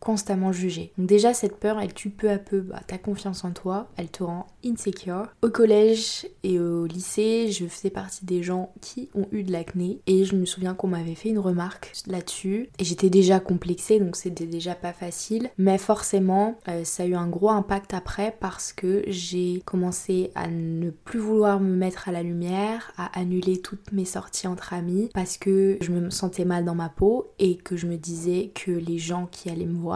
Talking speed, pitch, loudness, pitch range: 210 wpm, 185 Hz, -25 LUFS, 180-200 Hz